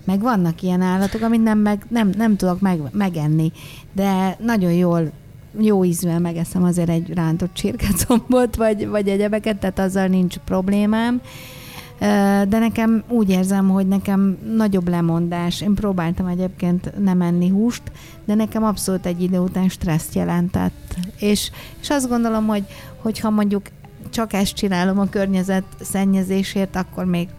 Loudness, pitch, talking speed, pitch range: -19 LUFS, 195 Hz, 145 wpm, 180-210 Hz